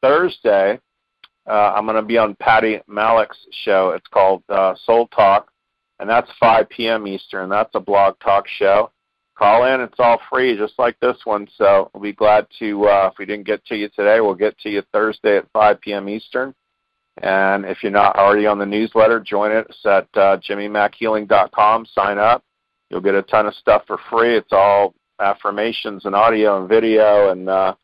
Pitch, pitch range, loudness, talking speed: 105 Hz, 100-110 Hz, -16 LUFS, 190 wpm